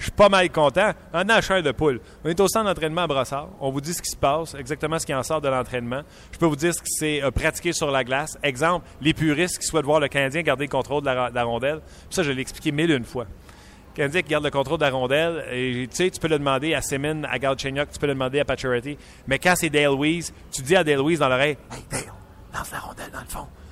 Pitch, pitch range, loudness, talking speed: 145 Hz, 135-165 Hz, -23 LUFS, 280 wpm